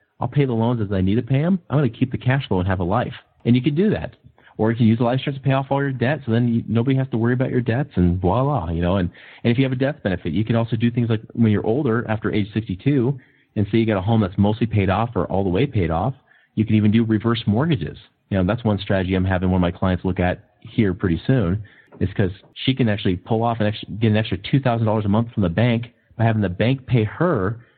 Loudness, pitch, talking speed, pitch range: -21 LUFS, 115 Hz, 290 wpm, 100-125 Hz